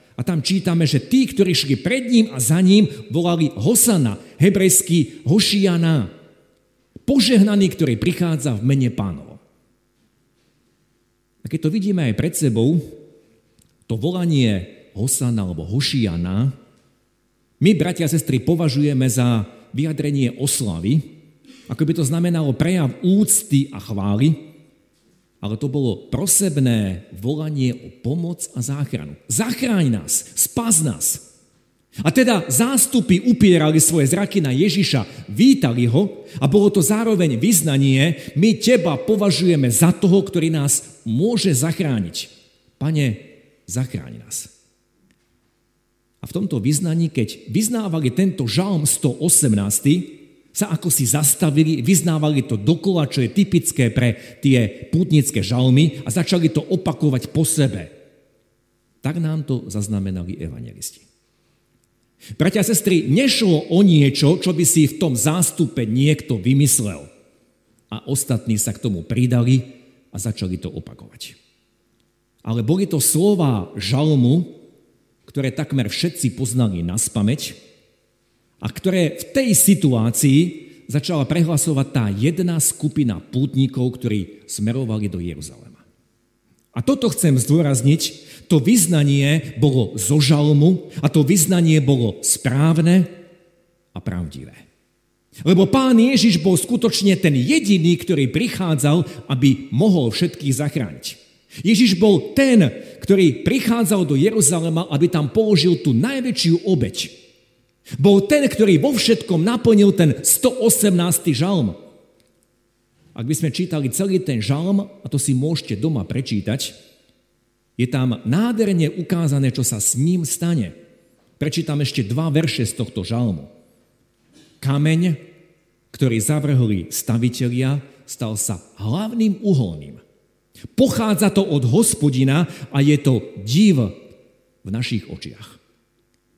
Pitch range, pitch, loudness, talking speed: 125-175 Hz, 150 Hz, -18 LUFS, 120 wpm